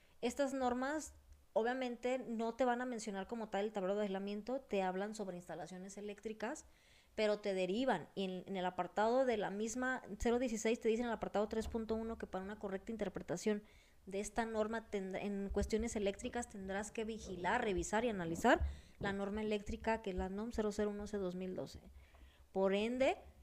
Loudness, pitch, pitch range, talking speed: -40 LUFS, 210 Hz, 190-230 Hz, 165 wpm